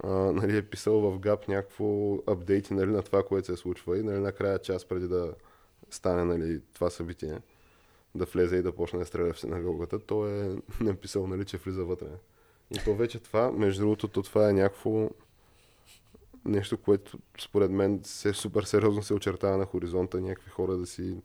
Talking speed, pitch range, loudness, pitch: 180 wpm, 90-105 Hz, -30 LUFS, 100 Hz